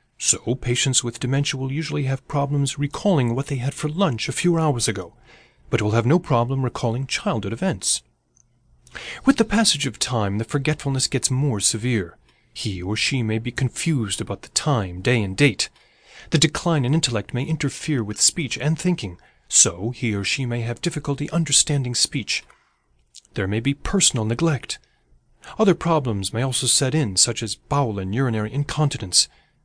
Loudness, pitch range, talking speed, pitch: -21 LUFS, 115-150 Hz, 170 wpm, 130 Hz